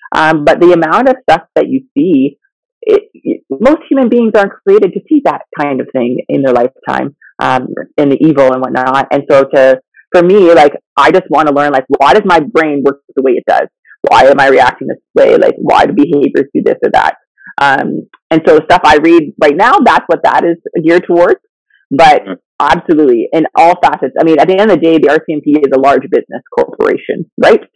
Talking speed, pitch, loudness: 220 wpm, 175 Hz, -9 LUFS